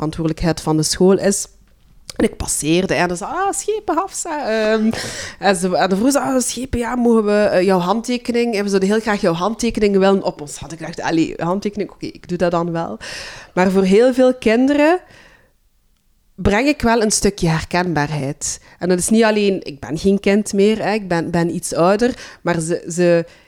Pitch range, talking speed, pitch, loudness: 170-230 Hz, 195 wpm, 195 Hz, -17 LUFS